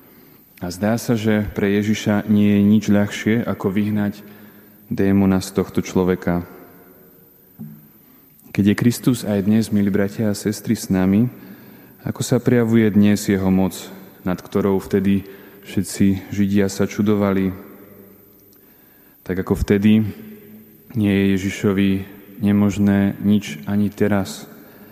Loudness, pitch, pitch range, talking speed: -19 LUFS, 100 Hz, 95-105 Hz, 120 wpm